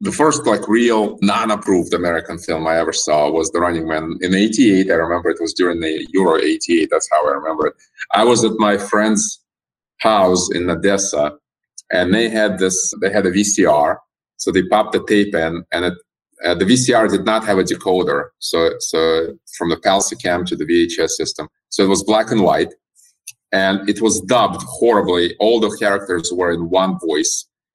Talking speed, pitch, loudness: 190 wpm, 100 Hz, -16 LUFS